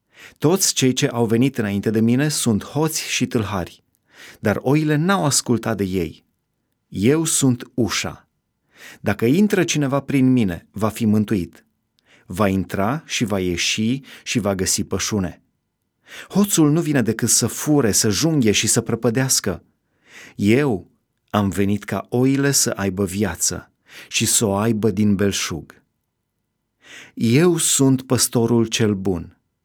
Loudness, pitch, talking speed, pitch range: -19 LUFS, 115 Hz, 140 wpm, 100-135 Hz